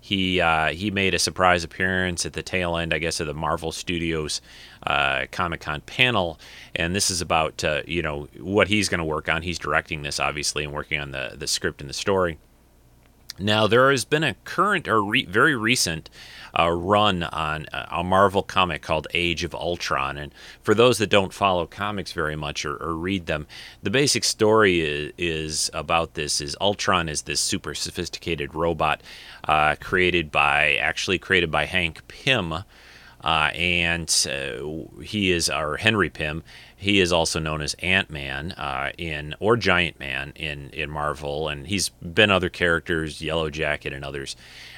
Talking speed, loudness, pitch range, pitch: 180 wpm, -23 LUFS, 75-95 Hz, 85 Hz